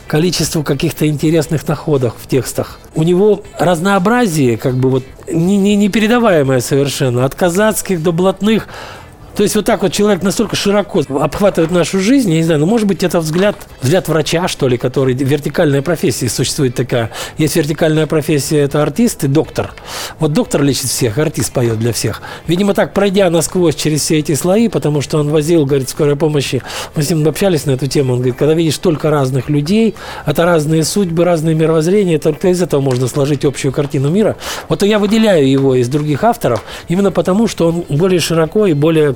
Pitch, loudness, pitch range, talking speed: 160 Hz, -13 LUFS, 140-185 Hz, 185 wpm